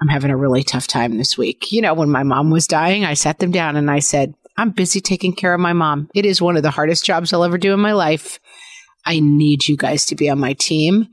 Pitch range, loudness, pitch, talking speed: 145-185 Hz, -16 LUFS, 155 Hz, 275 wpm